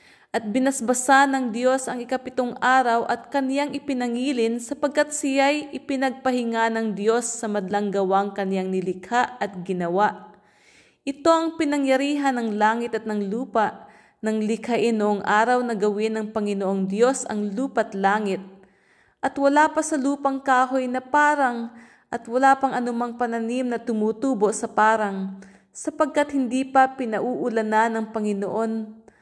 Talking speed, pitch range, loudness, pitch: 135 wpm, 215-265 Hz, -23 LUFS, 235 Hz